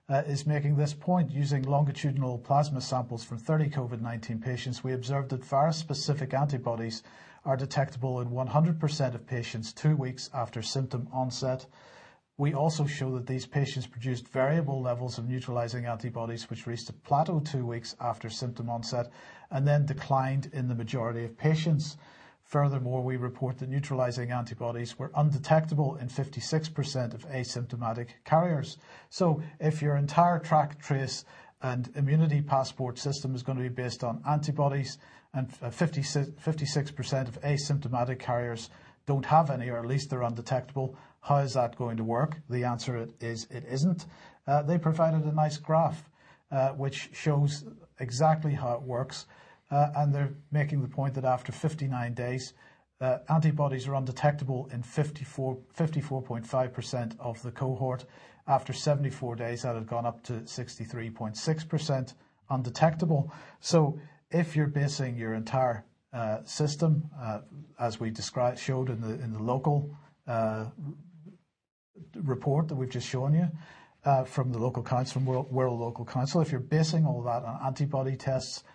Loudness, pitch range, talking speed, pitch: -30 LUFS, 125-145 Hz, 155 wpm, 135 Hz